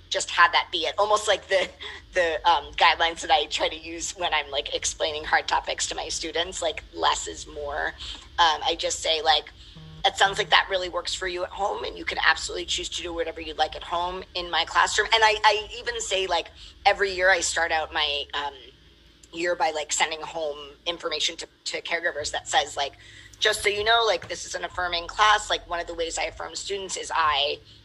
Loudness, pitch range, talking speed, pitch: -24 LUFS, 160-205 Hz, 225 wpm, 175 Hz